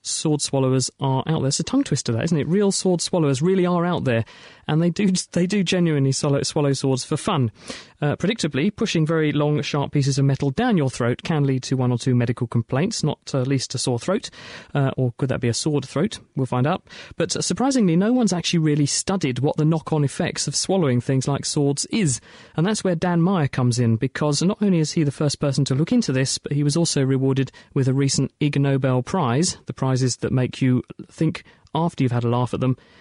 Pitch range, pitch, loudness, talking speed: 130-170 Hz, 145 Hz, -21 LUFS, 225 wpm